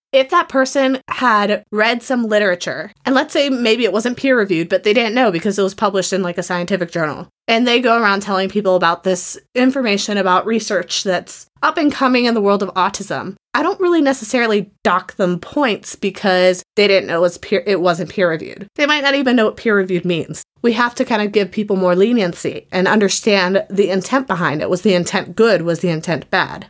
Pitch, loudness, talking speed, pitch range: 205 Hz, -16 LUFS, 220 wpm, 185-240 Hz